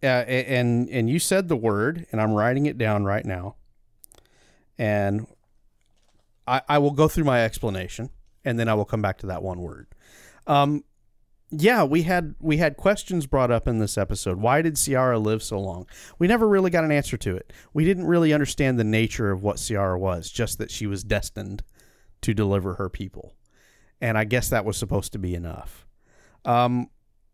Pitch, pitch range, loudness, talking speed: 115 Hz, 100-145 Hz, -23 LUFS, 190 wpm